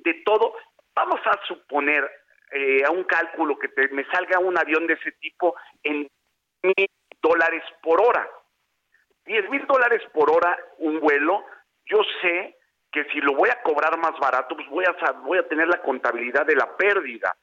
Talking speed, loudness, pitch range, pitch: 170 wpm, -22 LUFS, 155-195 Hz, 165 Hz